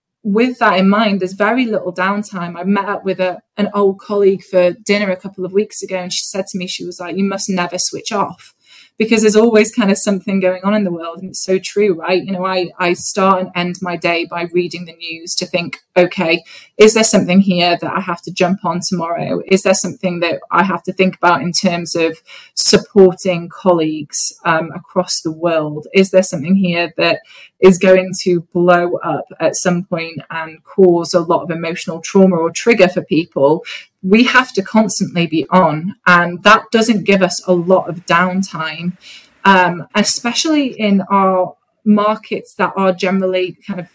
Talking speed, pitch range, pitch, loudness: 200 wpm, 175-195 Hz, 185 Hz, -14 LUFS